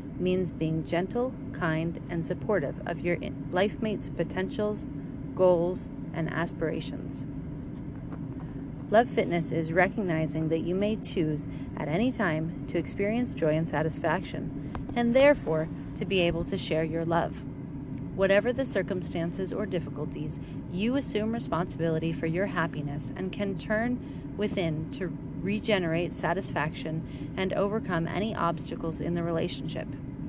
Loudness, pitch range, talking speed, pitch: -30 LUFS, 145-190 Hz, 125 wpm, 165 Hz